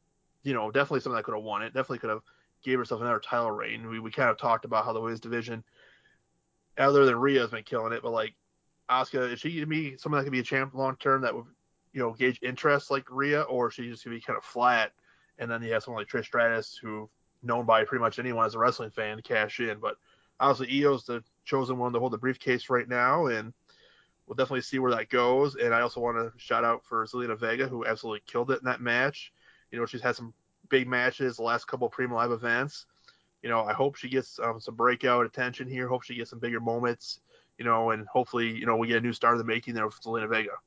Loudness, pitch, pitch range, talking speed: -29 LUFS, 120 Hz, 115-130 Hz, 250 wpm